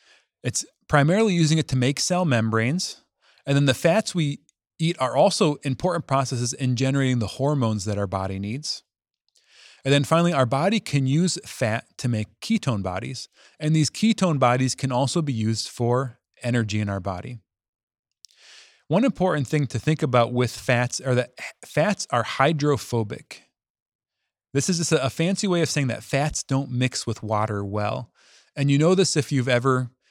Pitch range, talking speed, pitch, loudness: 120-160 Hz, 170 wpm, 135 Hz, -23 LUFS